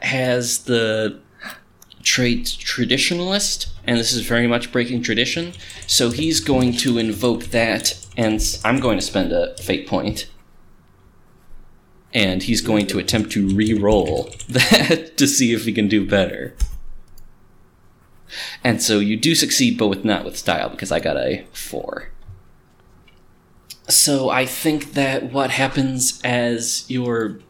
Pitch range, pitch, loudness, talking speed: 105-130 Hz, 120 Hz, -19 LUFS, 140 wpm